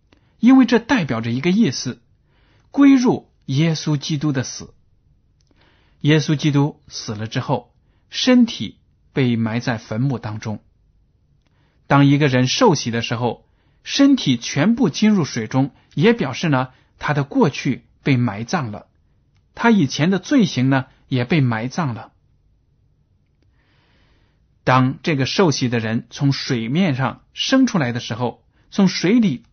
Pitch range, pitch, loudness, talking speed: 120-190 Hz, 140 Hz, -18 LUFS, 195 characters per minute